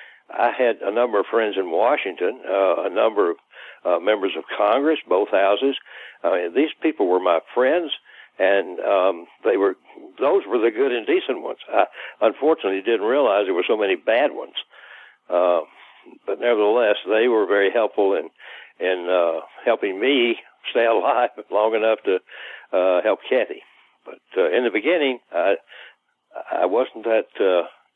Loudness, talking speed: -21 LUFS, 165 wpm